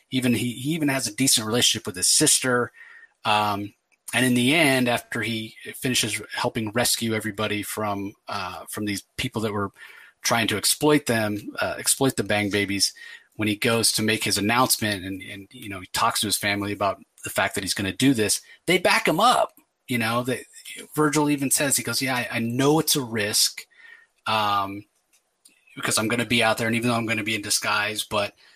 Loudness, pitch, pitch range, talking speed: -23 LUFS, 115 Hz, 105-130 Hz, 210 wpm